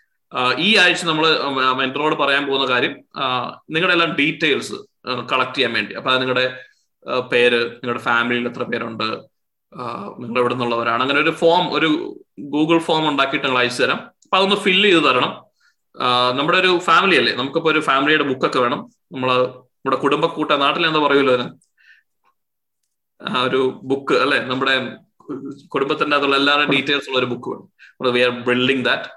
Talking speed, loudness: 140 wpm, -17 LUFS